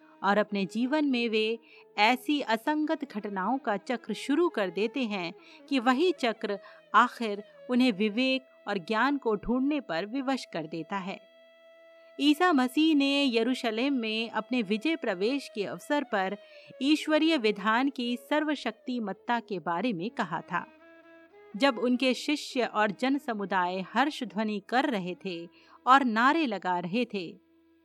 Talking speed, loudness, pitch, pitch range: 140 wpm, -28 LUFS, 250 Hz, 210-295 Hz